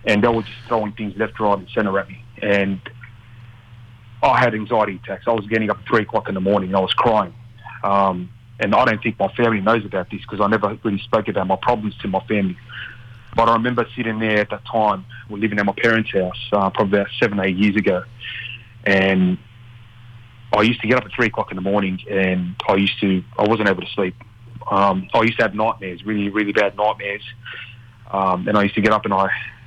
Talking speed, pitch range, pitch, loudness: 230 wpm, 100-115 Hz, 110 Hz, -19 LUFS